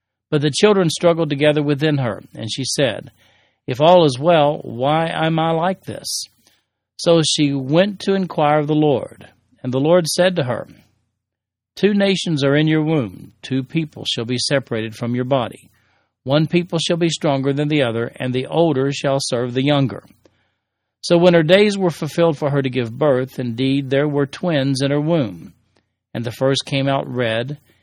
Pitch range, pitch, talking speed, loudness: 125-160 Hz, 140 Hz, 185 wpm, -18 LUFS